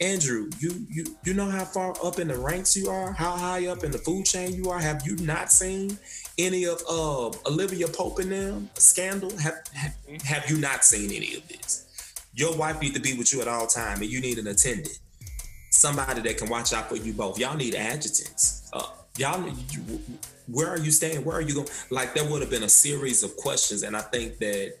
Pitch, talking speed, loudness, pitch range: 160 Hz, 225 wpm, -24 LUFS, 130-180 Hz